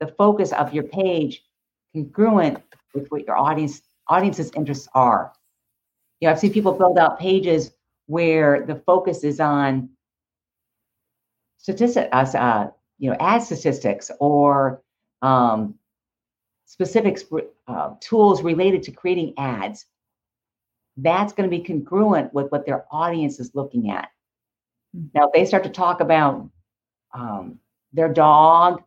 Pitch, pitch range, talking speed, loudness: 150 Hz, 130-180 Hz, 130 wpm, -19 LUFS